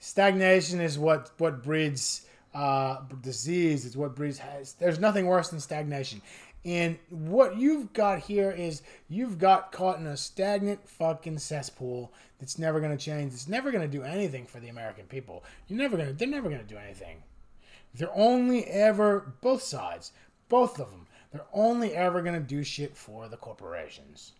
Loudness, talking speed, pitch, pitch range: -28 LUFS, 165 wpm, 160 Hz, 135-195 Hz